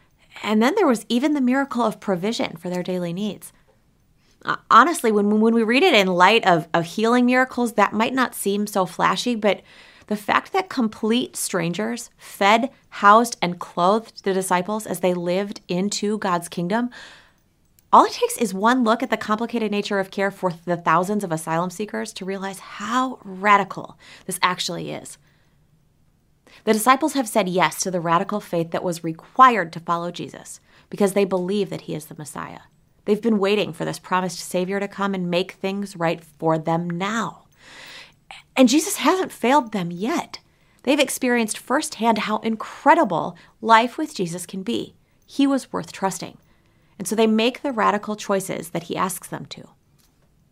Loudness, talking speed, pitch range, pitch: -21 LUFS, 175 wpm, 185-235 Hz, 205 Hz